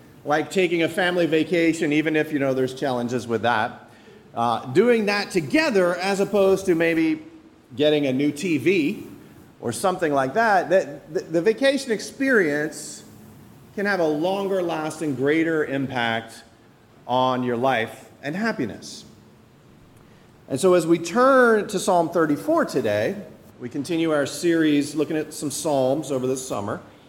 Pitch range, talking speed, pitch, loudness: 135-190 Hz, 140 wpm, 155 Hz, -22 LUFS